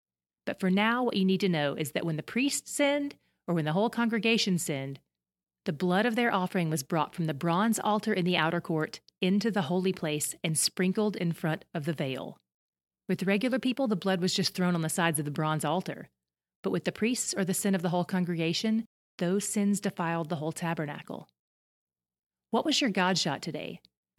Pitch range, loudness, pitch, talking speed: 155-200 Hz, -29 LUFS, 180 Hz, 210 wpm